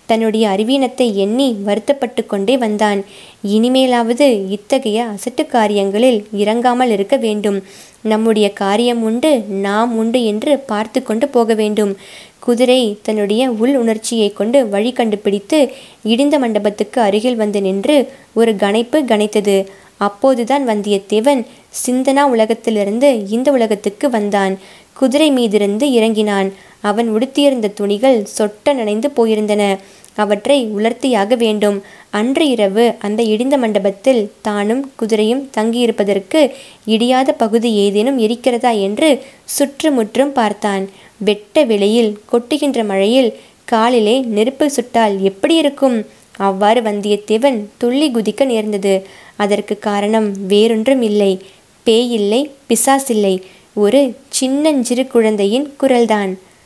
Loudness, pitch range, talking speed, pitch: -14 LUFS, 205-255 Hz, 105 wpm, 225 Hz